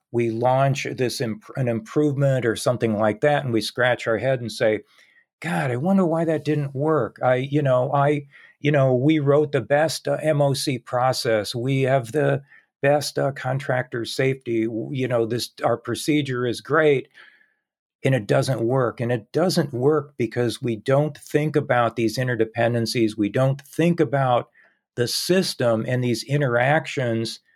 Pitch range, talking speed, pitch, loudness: 120-150 Hz, 165 wpm, 130 Hz, -22 LUFS